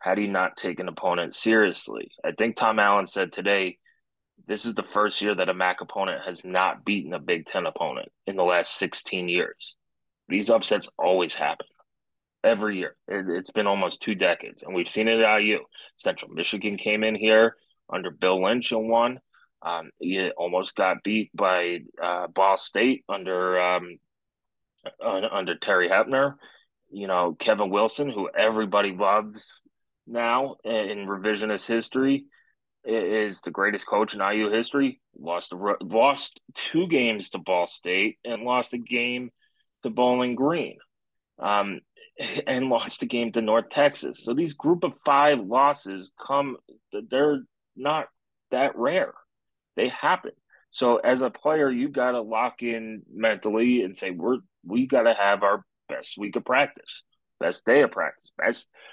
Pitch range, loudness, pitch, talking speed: 100-125 Hz, -25 LUFS, 110 Hz, 160 wpm